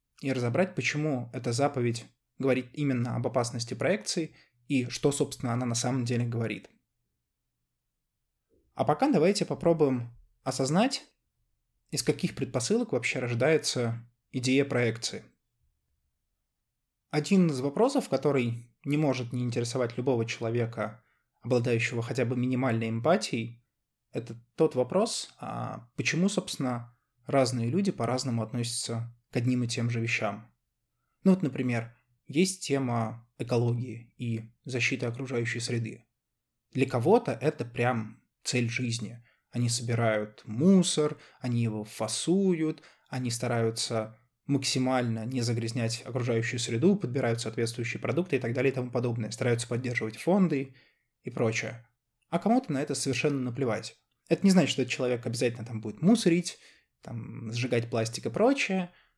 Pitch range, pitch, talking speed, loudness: 115-140 Hz, 125 Hz, 125 wpm, -29 LUFS